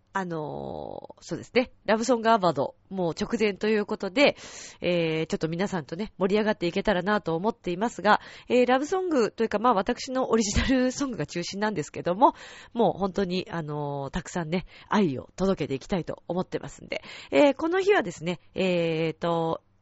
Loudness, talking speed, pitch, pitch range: -26 LUFS, 405 characters per minute, 195 Hz, 170-230 Hz